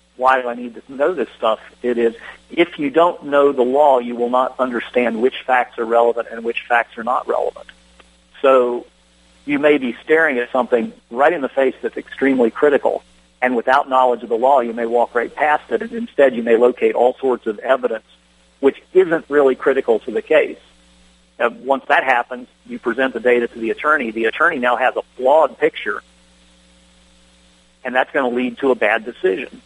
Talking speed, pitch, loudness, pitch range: 200 wpm, 120 Hz, -17 LUFS, 110-135 Hz